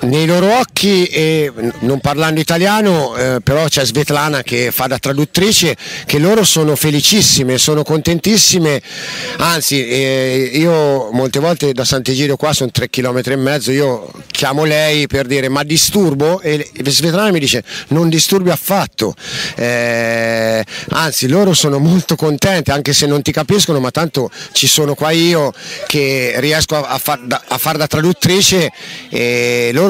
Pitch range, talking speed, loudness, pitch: 135-165 Hz, 155 wpm, -13 LUFS, 150 Hz